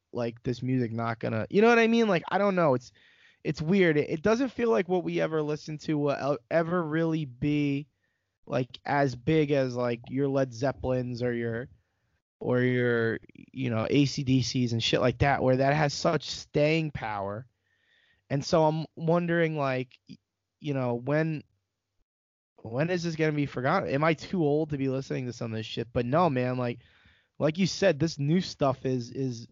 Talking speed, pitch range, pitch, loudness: 190 wpm, 120-155 Hz, 140 Hz, -28 LUFS